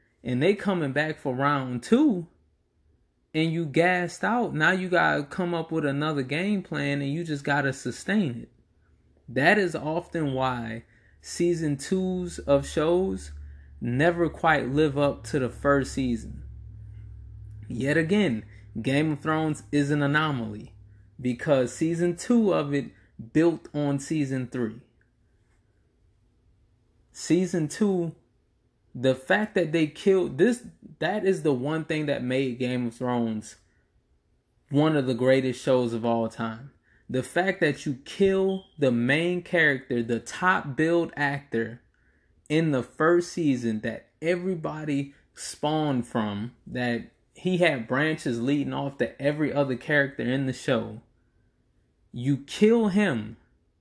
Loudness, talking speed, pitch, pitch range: -26 LUFS, 135 wpm, 140 Hz, 115-165 Hz